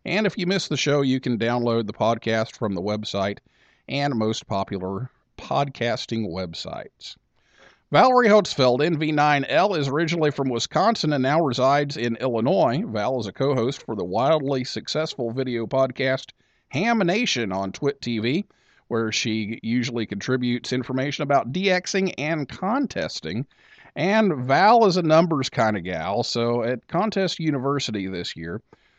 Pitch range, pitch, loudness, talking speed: 115-155 Hz, 130 Hz, -23 LUFS, 145 wpm